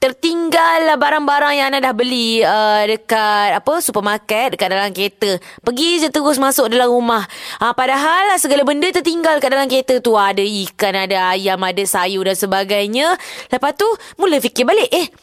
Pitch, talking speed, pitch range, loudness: 250 Hz, 175 wpm, 205-300 Hz, -15 LUFS